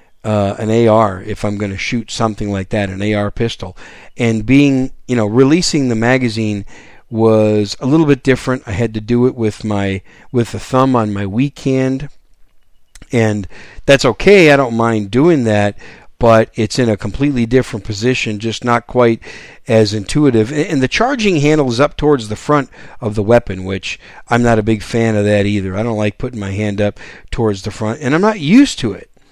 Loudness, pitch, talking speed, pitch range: -14 LUFS, 115 Hz, 200 wpm, 105-130 Hz